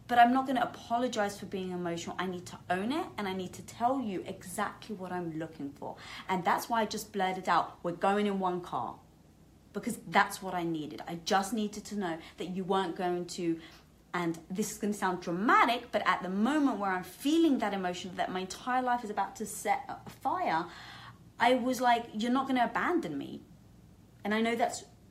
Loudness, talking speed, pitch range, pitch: -32 LUFS, 215 wpm, 180-235 Hz, 200 Hz